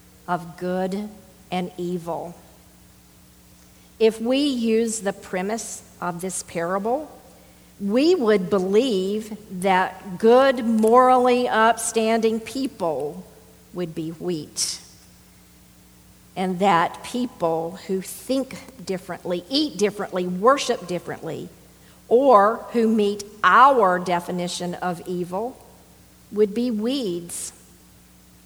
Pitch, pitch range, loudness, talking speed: 190 Hz, 175-225 Hz, -22 LUFS, 90 wpm